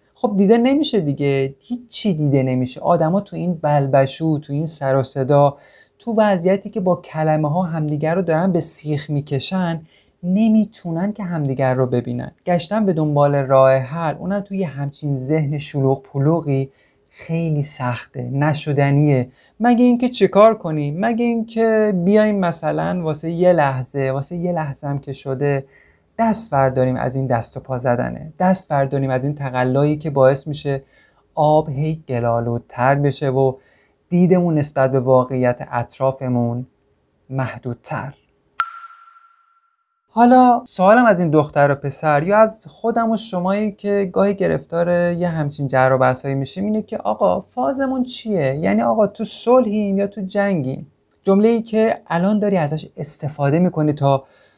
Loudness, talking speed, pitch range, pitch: -18 LUFS, 150 wpm, 135-200 Hz, 155 Hz